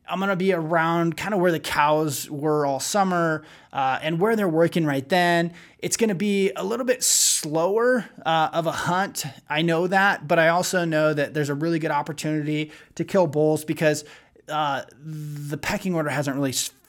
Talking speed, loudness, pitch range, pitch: 190 wpm, -22 LUFS, 150-180 Hz, 160 Hz